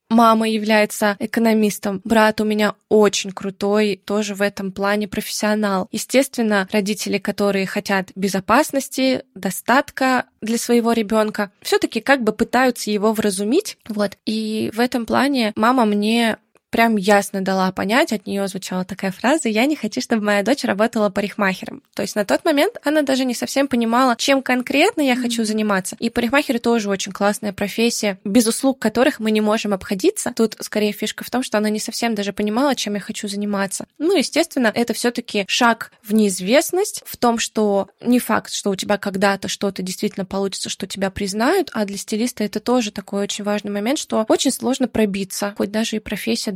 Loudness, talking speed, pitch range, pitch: -19 LUFS, 175 wpm, 205-245 Hz, 215 Hz